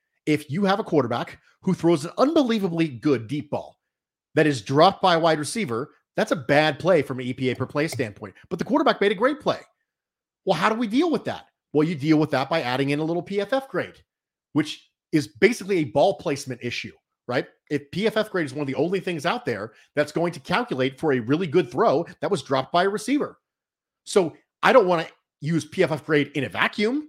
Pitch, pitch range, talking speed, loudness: 160 Hz, 145-195 Hz, 220 wpm, -23 LUFS